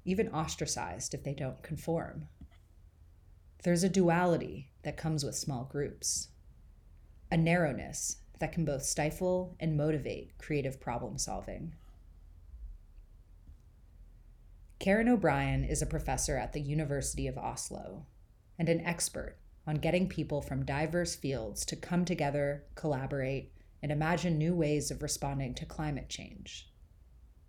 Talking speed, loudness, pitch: 125 wpm, -34 LUFS, 145 Hz